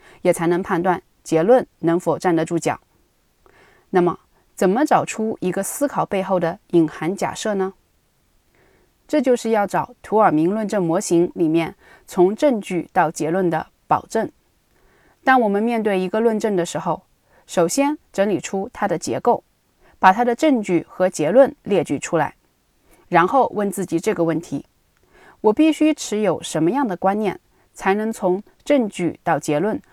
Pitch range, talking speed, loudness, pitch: 170-220 Hz, 230 characters per minute, -20 LUFS, 190 Hz